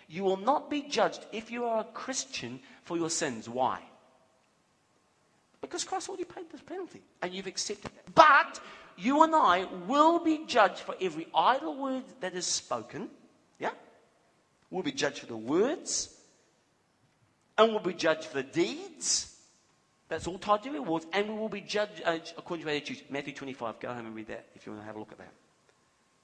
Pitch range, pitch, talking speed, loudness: 160-265 Hz, 190 Hz, 185 wpm, -30 LUFS